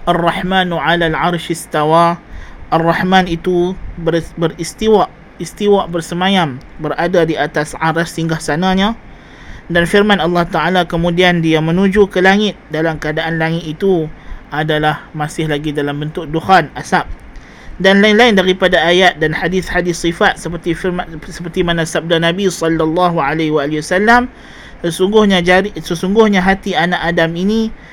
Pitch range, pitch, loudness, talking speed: 165-185 Hz, 170 Hz, -14 LUFS, 125 wpm